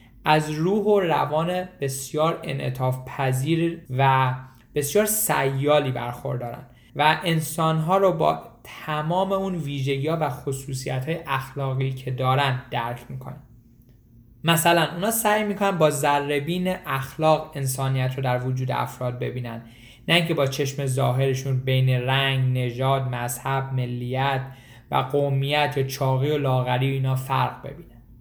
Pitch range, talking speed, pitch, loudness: 130-155 Hz, 130 wpm, 135 Hz, -23 LUFS